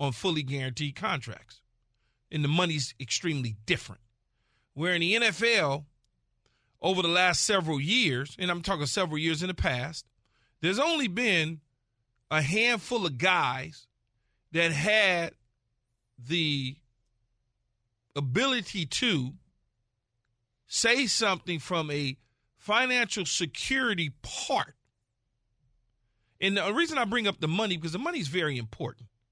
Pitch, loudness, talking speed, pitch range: 145 Hz, -28 LUFS, 120 wpm, 120-180 Hz